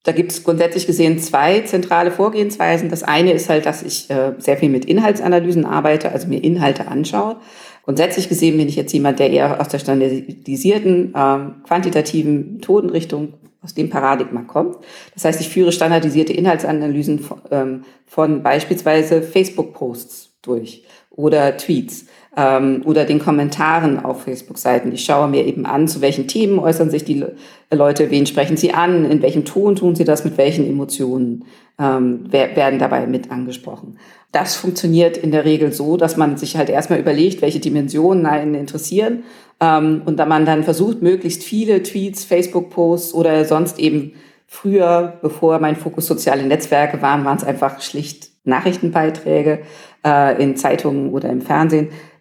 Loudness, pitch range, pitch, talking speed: -16 LUFS, 140-170 Hz, 155 Hz, 160 wpm